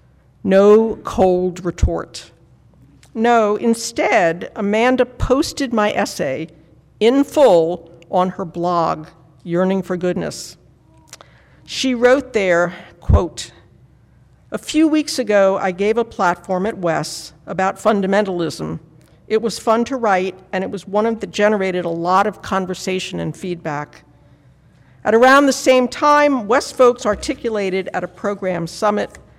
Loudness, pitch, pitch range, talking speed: -17 LUFS, 200 Hz, 180-230 Hz, 125 wpm